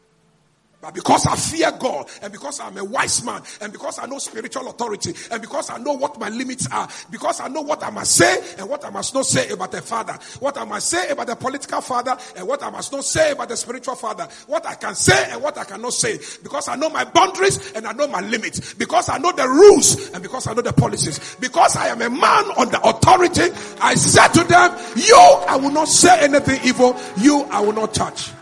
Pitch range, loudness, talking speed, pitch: 250-315 Hz, -17 LUFS, 240 wpm, 280 Hz